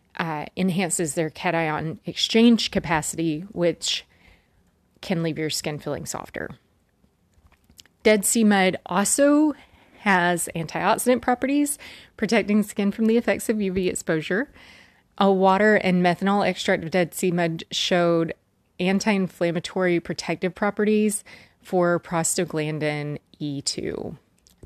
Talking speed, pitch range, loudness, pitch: 110 wpm, 165-205 Hz, -23 LUFS, 185 Hz